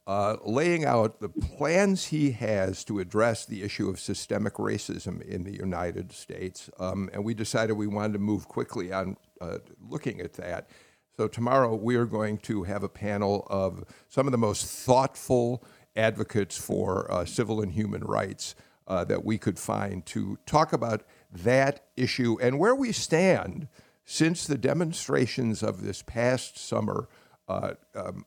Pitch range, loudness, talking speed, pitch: 100-125 Hz, -28 LUFS, 165 wpm, 110 Hz